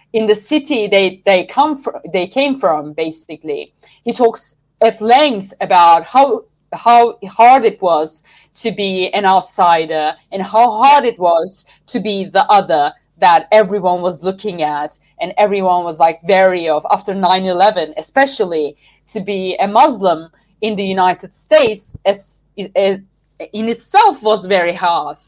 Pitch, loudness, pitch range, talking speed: 195 Hz, -13 LUFS, 170-220 Hz, 150 wpm